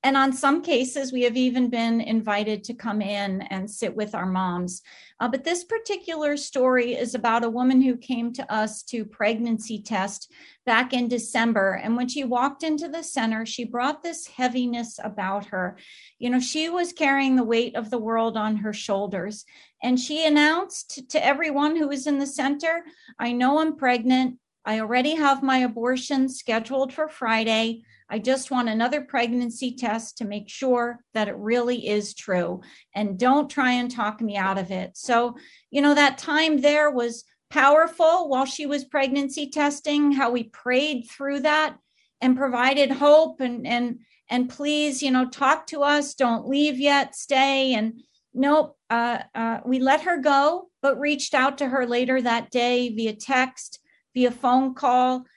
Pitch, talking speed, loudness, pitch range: 255 Hz, 175 wpm, -23 LUFS, 230-285 Hz